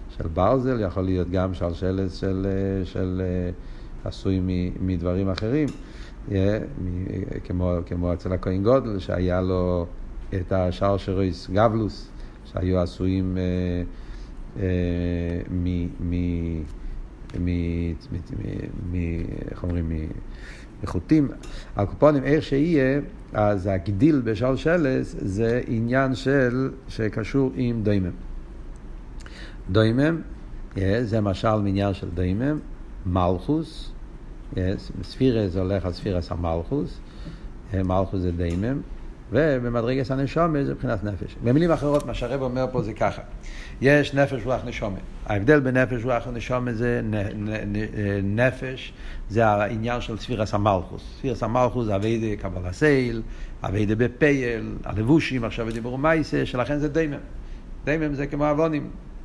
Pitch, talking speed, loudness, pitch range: 105 Hz, 105 wpm, -24 LUFS, 90-130 Hz